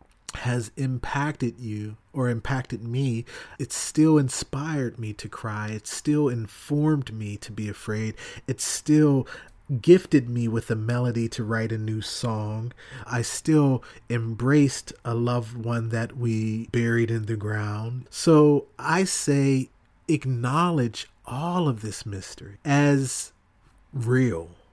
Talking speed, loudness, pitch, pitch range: 130 wpm, -25 LUFS, 120 Hz, 110-135 Hz